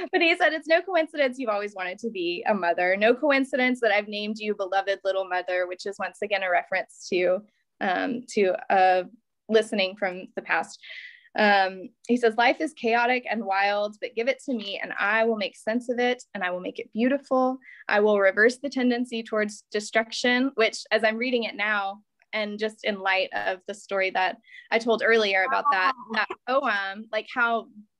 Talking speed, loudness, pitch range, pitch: 200 wpm, -25 LUFS, 195-250 Hz, 220 Hz